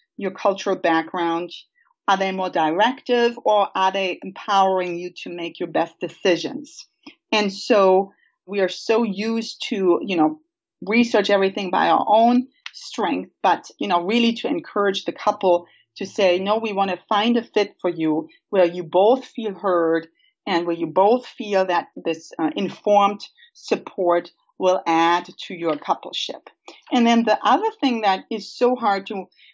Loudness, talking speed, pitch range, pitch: -21 LUFS, 165 wpm, 180-235 Hz, 200 Hz